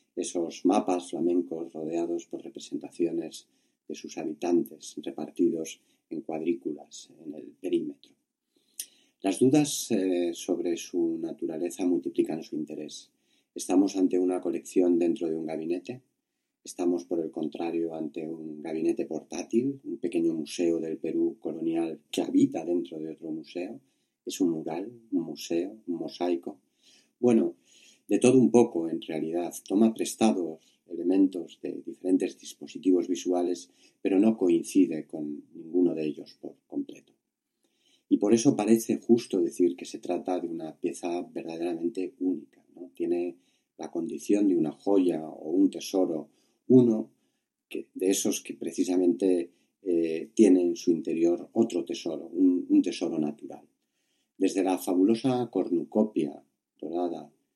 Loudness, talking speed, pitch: -28 LUFS, 130 wpm, 290 Hz